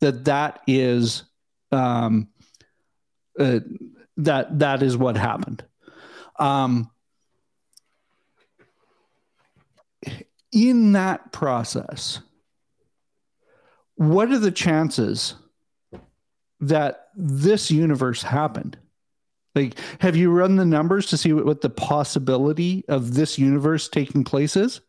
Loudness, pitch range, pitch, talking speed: -21 LUFS, 135-185 Hz, 150 Hz, 95 wpm